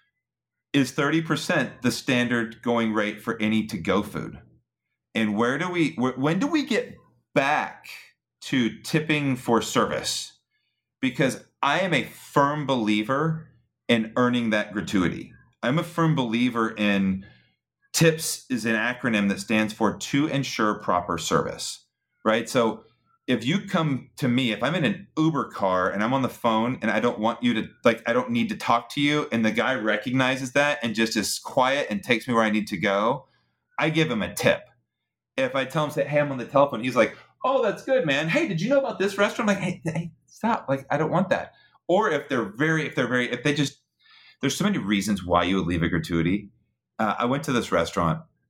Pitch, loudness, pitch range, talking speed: 130 Hz, -24 LUFS, 110-160 Hz, 205 wpm